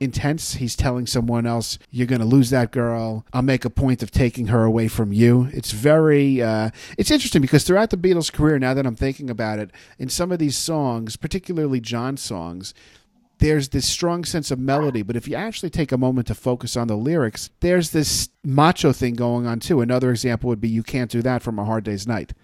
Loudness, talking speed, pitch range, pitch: -21 LUFS, 220 wpm, 115-145 Hz, 125 Hz